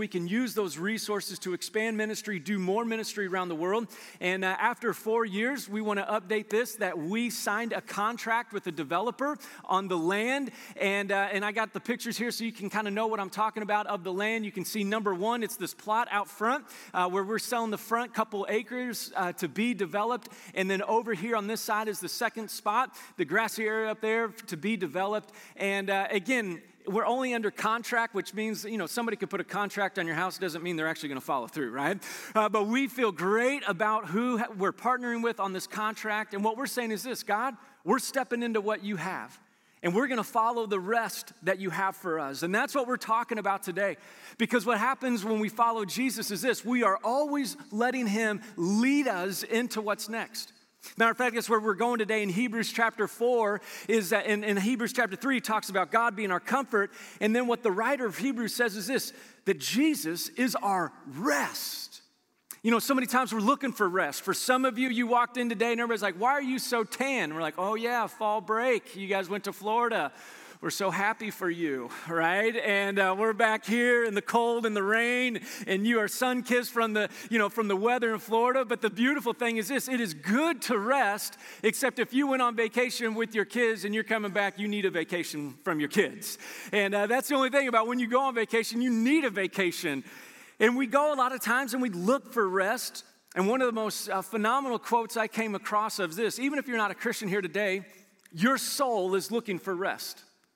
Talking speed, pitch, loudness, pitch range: 230 wpm, 220 Hz, -29 LUFS, 200-240 Hz